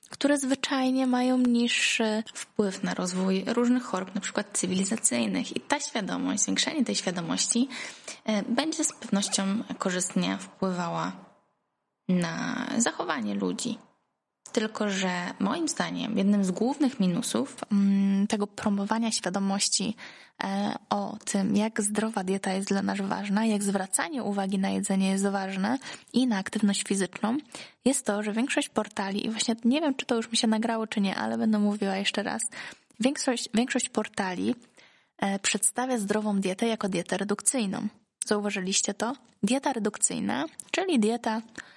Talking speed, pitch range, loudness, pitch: 135 wpm, 195-240 Hz, -28 LUFS, 215 Hz